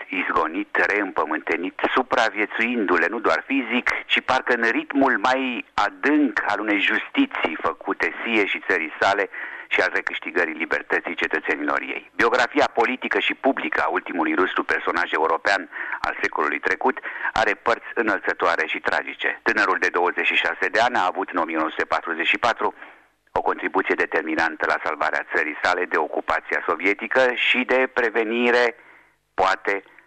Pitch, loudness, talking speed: 130 Hz, -22 LUFS, 130 wpm